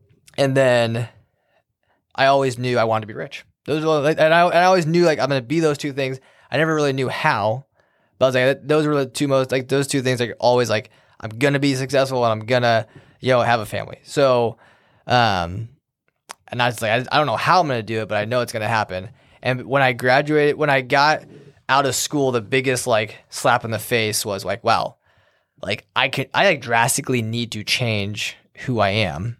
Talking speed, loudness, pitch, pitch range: 235 wpm, -19 LUFS, 130 Hz, 115-140 Hz